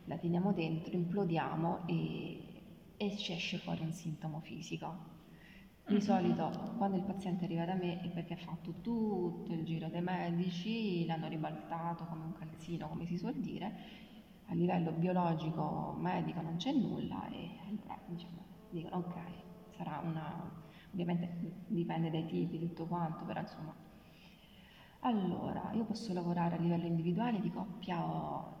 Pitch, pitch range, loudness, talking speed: 175 Hz, 170-195 Hz, -38 LUFS, 150 wpm